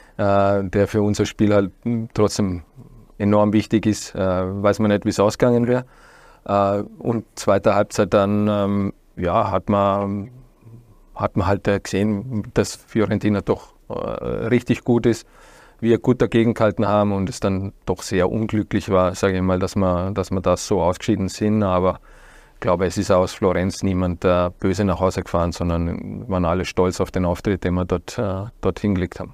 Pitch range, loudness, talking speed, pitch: 95-105 Hz, -20 LUFS, 165 wpm, 100 Hz